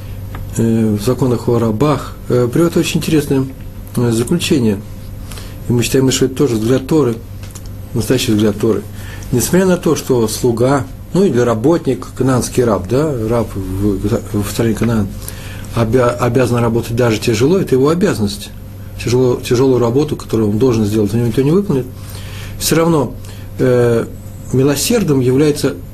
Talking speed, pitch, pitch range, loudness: 140 wpm, 120 Hz, 105-130 Hz, -14 LUFS